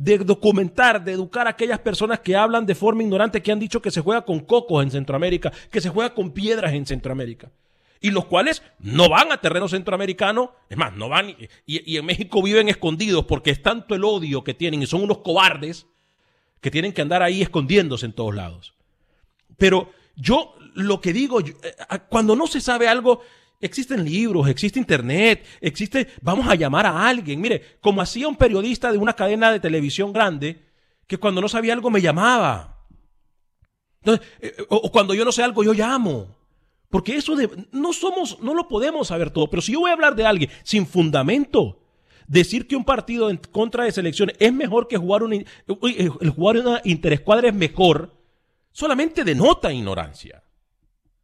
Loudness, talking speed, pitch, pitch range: -20 LUFS, 185 wpm, 200 Hz, 165-230 Hz